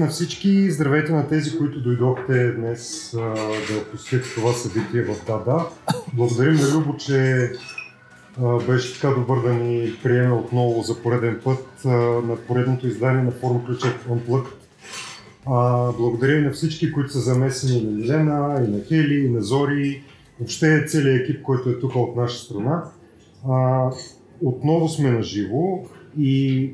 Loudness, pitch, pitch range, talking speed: -21 LUFS, 130 Hz, 120-145 Hz, 160 wpm